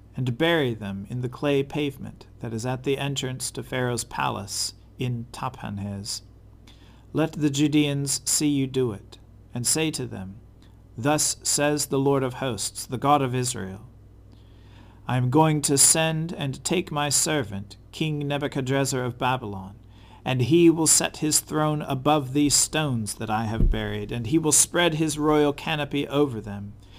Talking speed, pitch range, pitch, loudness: 160 wpm, 105-145 Hz, 130 Hz, -24 LUFS